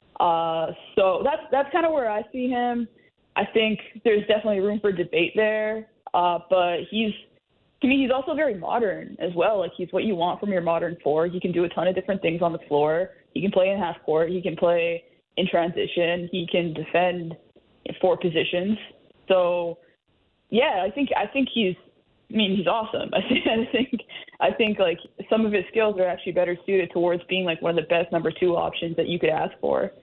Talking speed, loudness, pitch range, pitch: 215 wpm, -24 LUFS, 170-215 Hz, 185 Hz